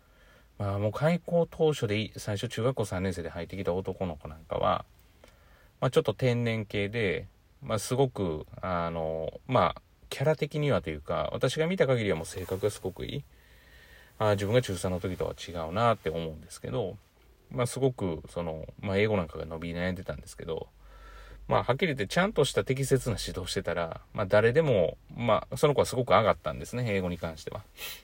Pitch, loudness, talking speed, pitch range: 100 Hz, -30 LUFS, 370 characters per minute, 85-125 Hz